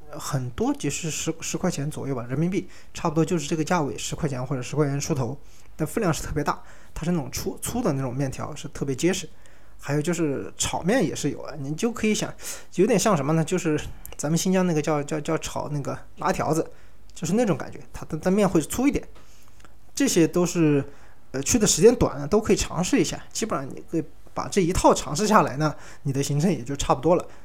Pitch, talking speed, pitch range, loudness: 155 Hz, 330 characters per minute, 140-175 Hz, -25 LUFS